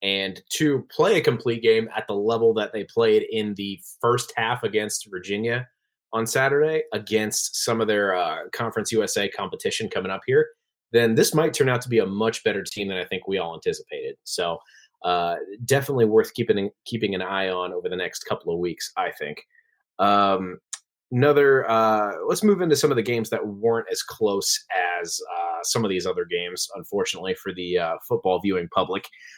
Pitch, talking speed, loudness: 115 Hz, 190 wpm, -23 LUFS